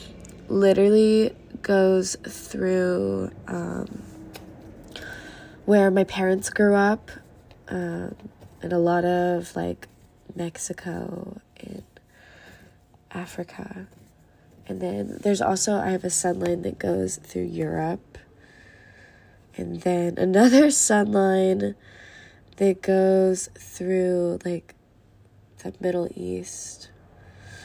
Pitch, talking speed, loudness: 175 Hz, 90 wpm, -23 LUFS